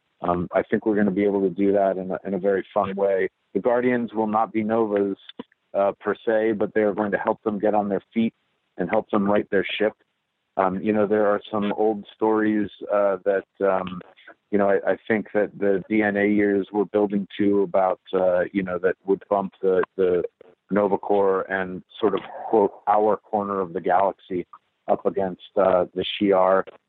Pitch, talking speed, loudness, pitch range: 100 Hz, 205 wpm, -23 LUFS, 95-110 Hz